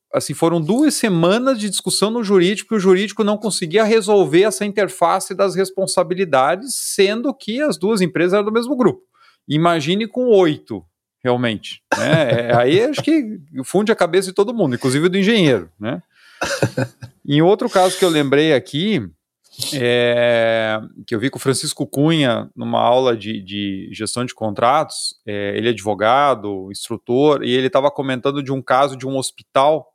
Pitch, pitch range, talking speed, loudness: 165 Hz, 125-200 Hz, 165 wpm, -17 LUFS